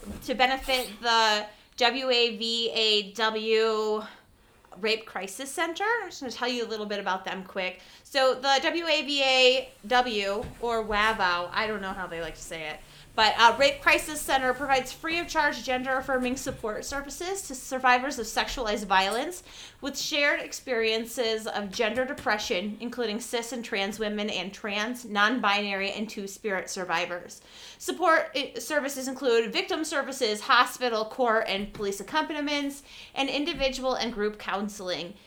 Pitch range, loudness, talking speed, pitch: 210-270 Hz, -27 LUFS, 145 wpm, 235 Hz